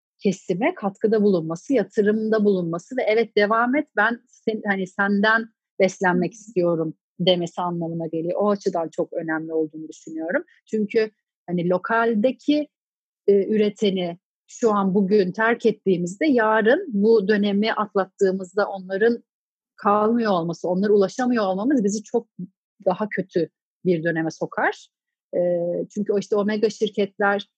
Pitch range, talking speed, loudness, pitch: 180-220 Hz, 125 wpm, -22 LUFS, 205 Hz